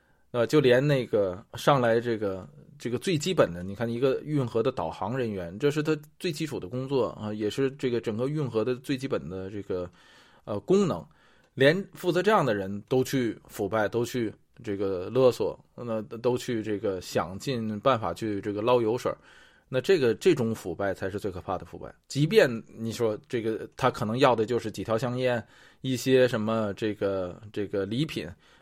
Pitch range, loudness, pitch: 105-135 Hz, -28 LUFS, 120 Hz